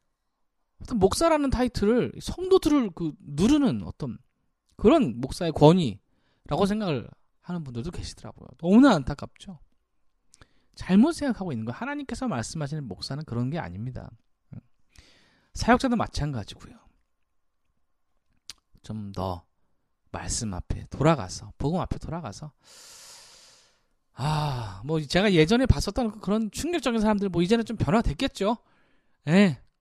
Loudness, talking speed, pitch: -25 LUFS, 280 characters per minute, 165 Hz